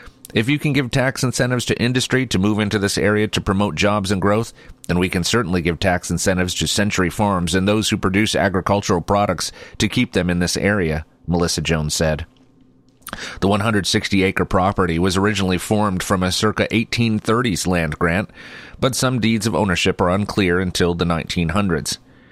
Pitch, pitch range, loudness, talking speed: 100 Hz, 90-110 Hz, -19 LUFS, 175 wpm